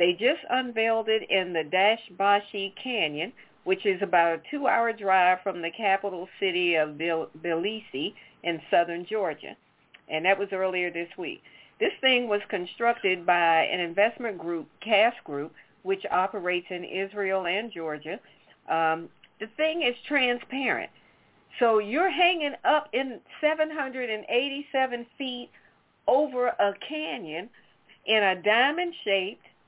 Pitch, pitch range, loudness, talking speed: 200 Hz, 180-245 Hz, -26 LUFS, 130 wpm